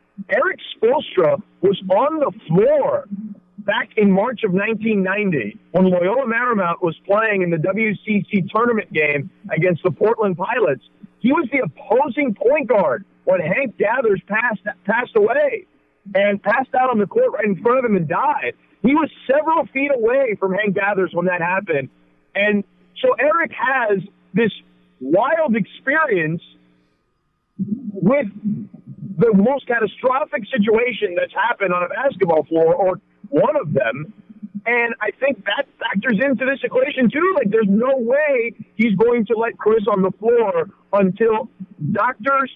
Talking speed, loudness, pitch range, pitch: 150 wpm, -18 LUFS, 195-270 Hz, 220 Hz